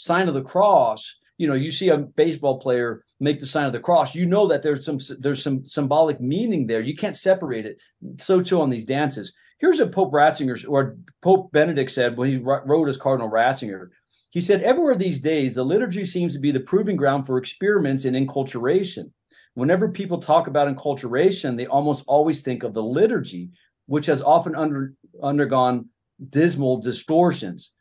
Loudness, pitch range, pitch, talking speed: -21 LUFS, 130-170 Hz, 145 Hz, 185 wpm